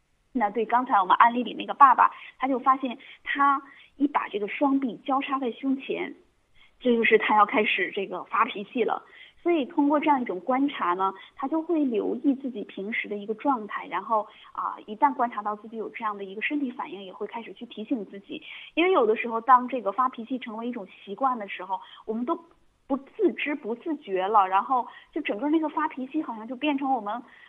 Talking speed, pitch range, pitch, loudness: 315 characters per minute, 210-280 Hz, 250 Hz, -26 LUFS